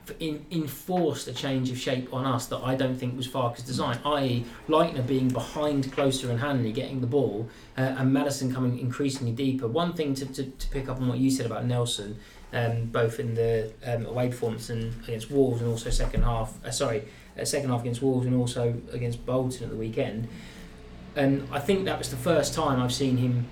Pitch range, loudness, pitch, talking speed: 120-140 Hz, -28 LUFS, 125 Hz, 210 wpm